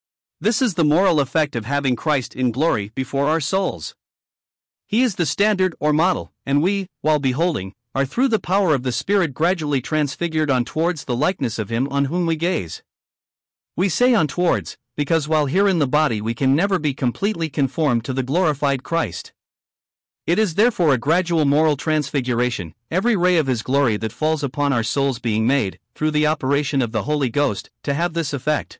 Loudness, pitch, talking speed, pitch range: -21 LUFS, 145 Hz, 190 wpm, 125-165 Hz